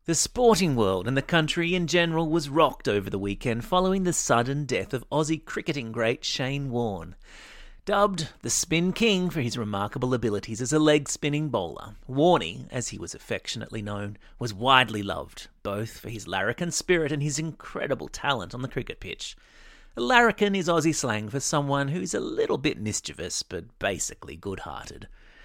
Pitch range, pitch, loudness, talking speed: 110-165 Hz, 140 Hz, -26 LUFS, 170 wpm